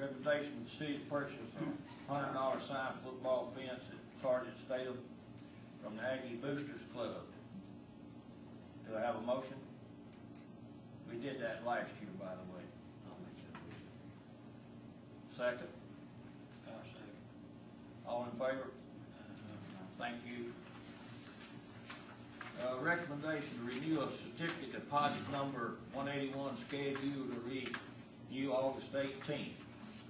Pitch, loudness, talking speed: 125 Hz, -43 LUFS, 105 wpm